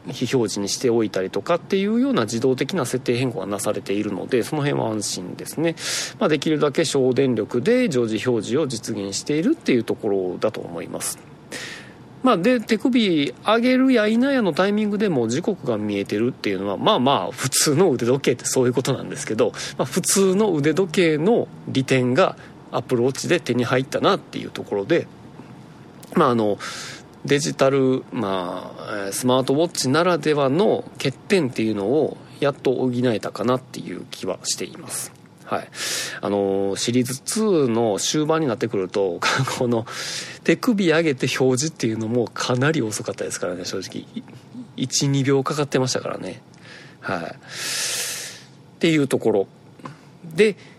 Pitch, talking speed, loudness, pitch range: 135 Hz, 340 characters per minute, -21 LUFS, 120-170 Hz